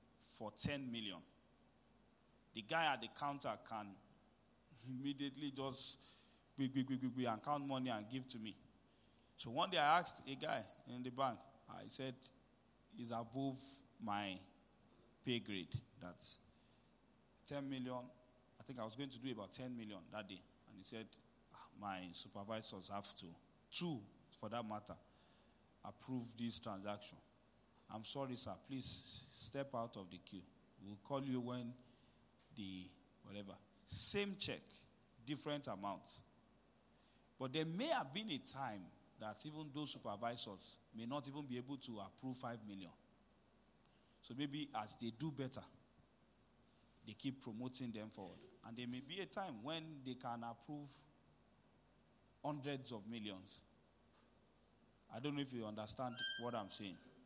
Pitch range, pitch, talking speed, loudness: 110-135 Hz, 125 Hz, 145 wpm, -47 LUFS